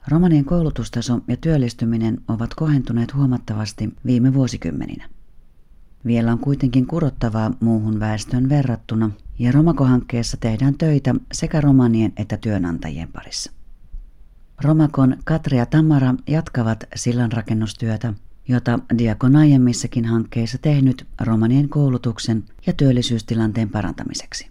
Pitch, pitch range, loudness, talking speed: 120 Hz, 110-135 Hz, -19 LUFS, 100 wpm